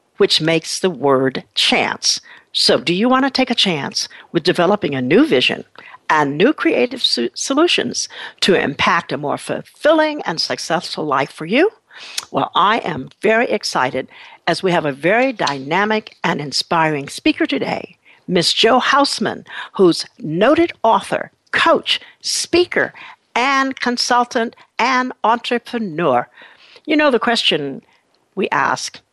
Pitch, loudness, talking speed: 235 Hz, -17 LUFS, 135 wpm